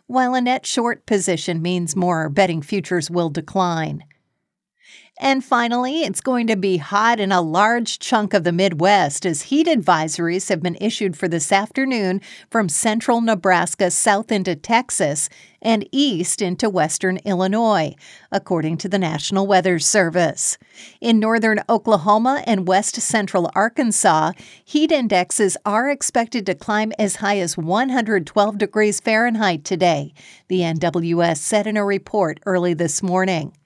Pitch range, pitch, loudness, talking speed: 175-225 Hz, 200 Hz, -19 LUFS, 145 wpm